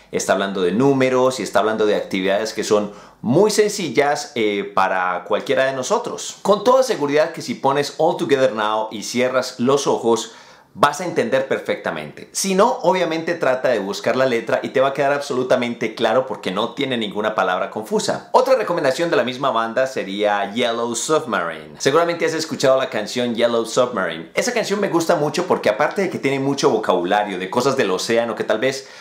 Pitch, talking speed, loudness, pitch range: 130 Hz, 190 wpm, -19 LUFS, 110-160 Hz